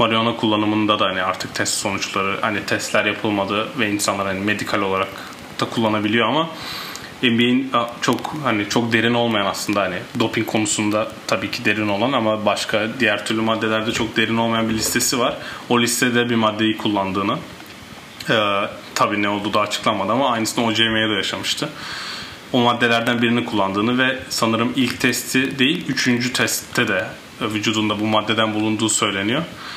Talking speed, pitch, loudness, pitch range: 155 wpm, 110 Hz, -19 LUFS, 105-120 Hz